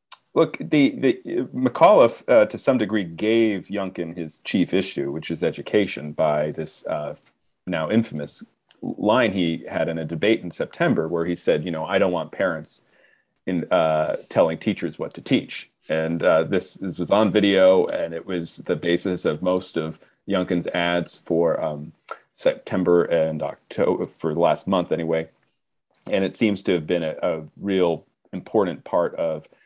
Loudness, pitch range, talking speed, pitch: -22 LUFS, 80-95 Hz, 170 wpm, 85 Hz